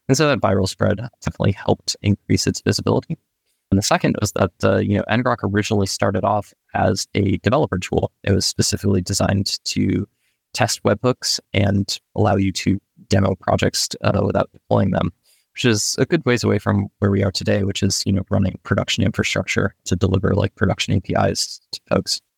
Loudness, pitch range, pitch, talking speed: -20 LUFS, 95-110 Hz, 100 Hz, 180 wpm